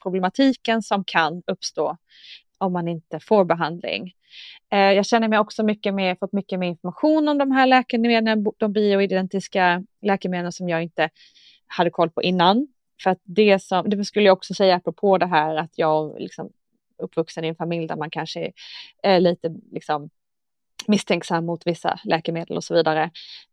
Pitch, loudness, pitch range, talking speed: 185 Hz, -21 LUFS, 170-210 Hz, 170 wpm